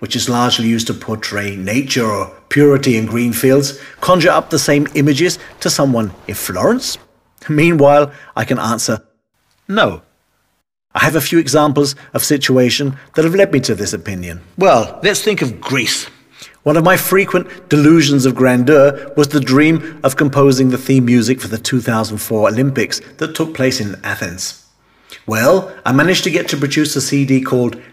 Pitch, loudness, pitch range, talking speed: 135 Hz, -14 LUFS, 115-150 Hz, 180 wpm